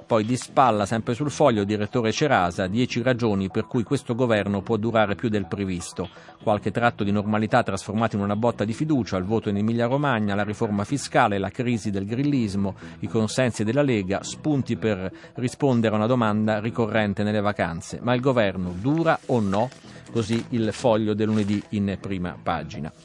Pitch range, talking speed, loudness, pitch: 100-120 Hz, 175 wpm, -24 LUFS, 110 Hz